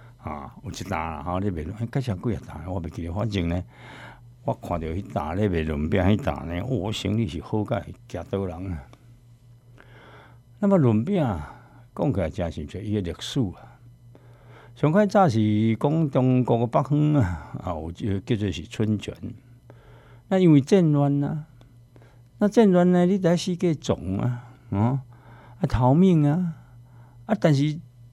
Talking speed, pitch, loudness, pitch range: 220 characters per minute, 120 Hz, -24 LUFS, 100-135 Hz